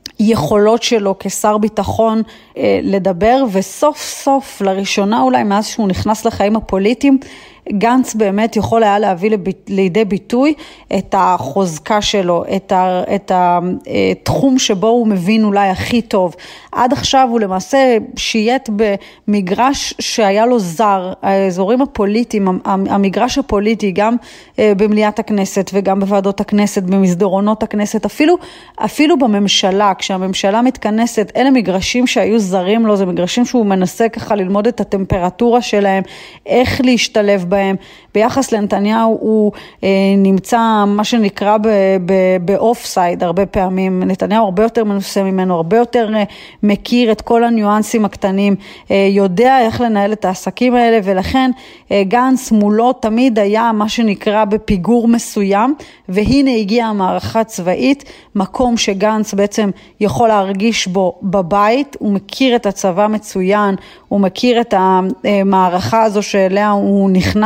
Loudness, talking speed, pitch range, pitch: -13 LUFS, 125 wpm, 195-230 Hz, 210 Hz